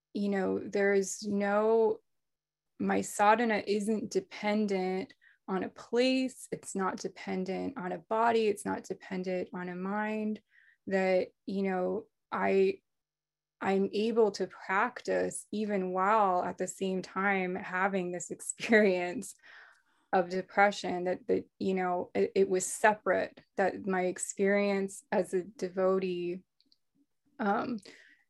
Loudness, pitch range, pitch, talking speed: -31 LUFS, 185-215 Hz, 195 Hz, 125 wpm